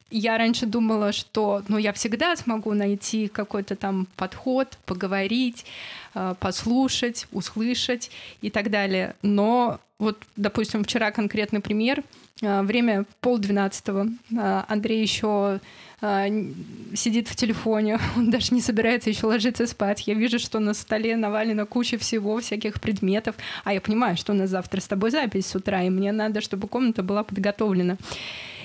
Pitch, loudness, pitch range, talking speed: 215 Hz, -25 LUFS, 200-230 Hz, 140 wpm